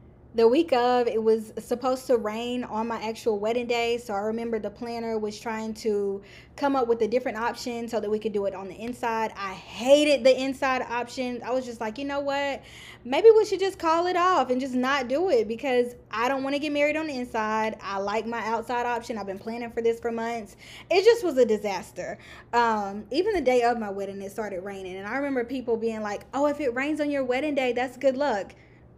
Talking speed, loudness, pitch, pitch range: 235 wpm, -26 LUFS, 240 Hz, 220-265 Hz